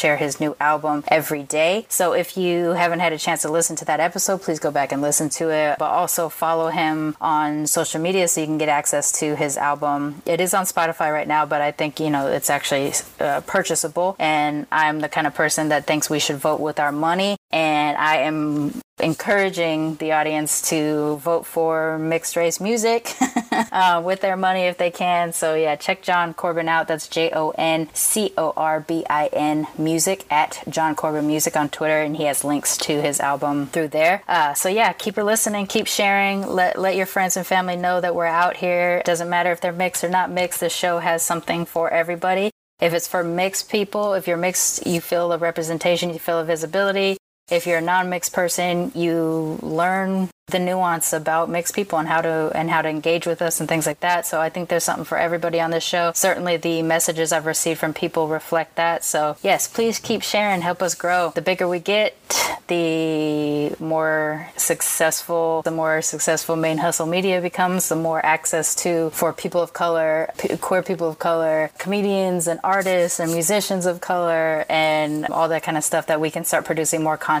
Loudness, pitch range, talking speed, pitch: -20 LUFS, 155-180 Hz, 200 wpm, 165 Hz